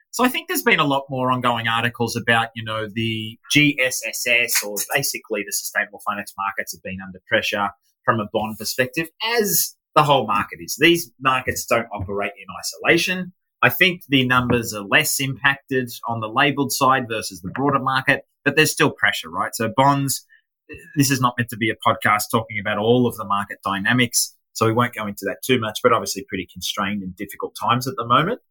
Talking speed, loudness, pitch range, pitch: 200 wpm, -20 LUFS, 110-140 Hz, 120 Hz